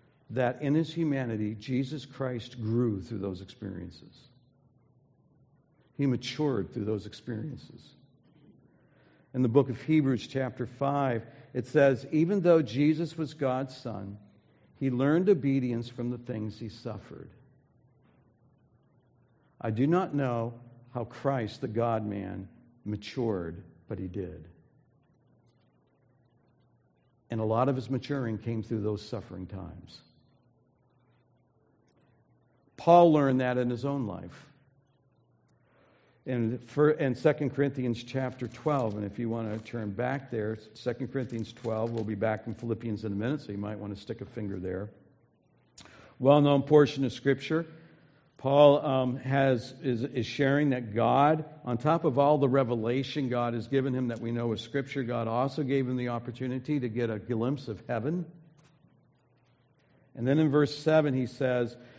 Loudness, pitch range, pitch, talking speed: -29 LUFS, 115-140 Hz, 125 Hz, 145 wpm